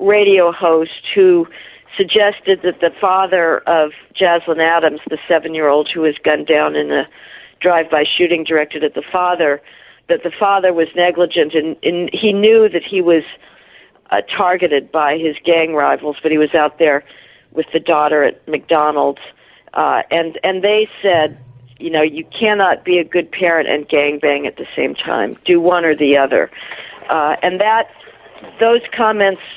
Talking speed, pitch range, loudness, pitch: 175 wpm, 155-185 Hz, -14 LUFS, 165 Hz